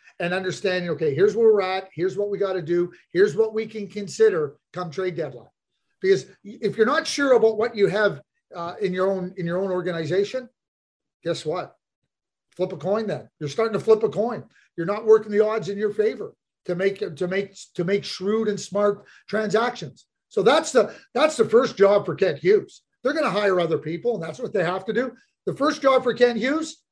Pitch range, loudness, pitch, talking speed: 185-245 Hz, -23 LUFS, 205 Hz, 215 wpm